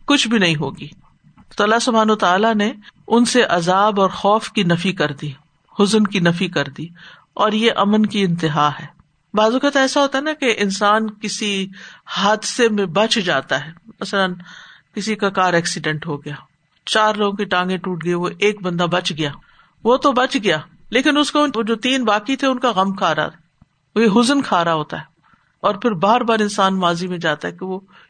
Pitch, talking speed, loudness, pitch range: 200 Hz, 200 wpm, -18 LUFS, 175-225 Hz